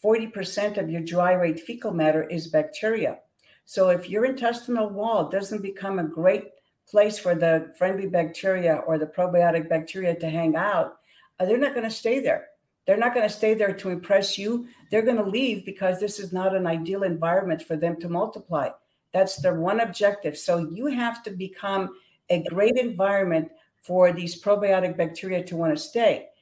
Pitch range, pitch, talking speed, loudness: 175-215 Hz, 190 Hz, 180 wpm, -25 LUFS